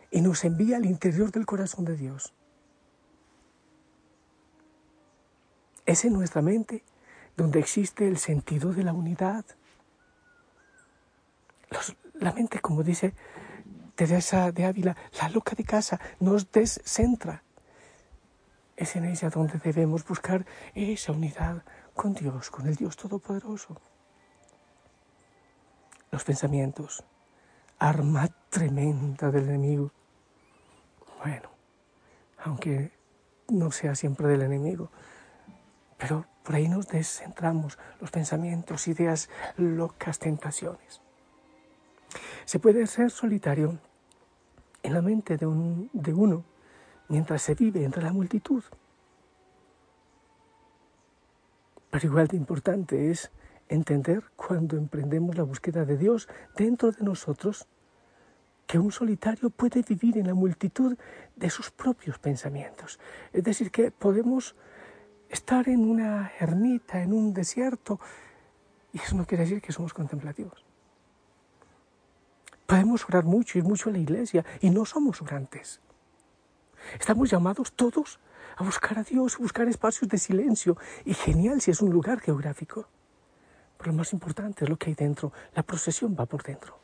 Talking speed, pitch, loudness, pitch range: 125 wpm, 175 Hz, -28 LUFS, 155-210 Hz